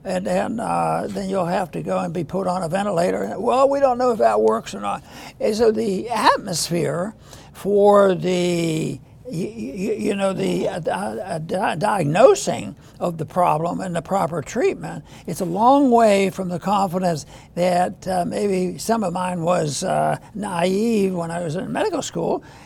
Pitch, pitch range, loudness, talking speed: 185 Hz, 175-205 Hz, -21 LUFS, 165 wpm